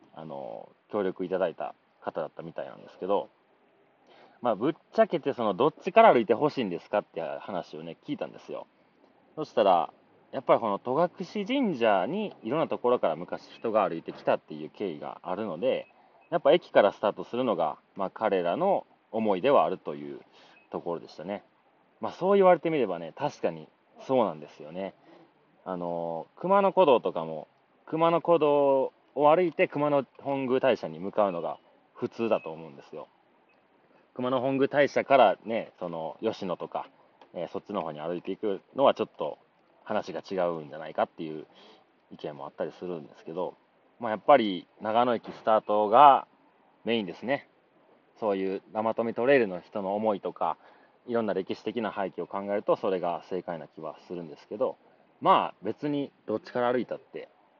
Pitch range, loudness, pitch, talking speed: 95-150 Hz, -28 LUFS, 120 Hz, 360 characters per minute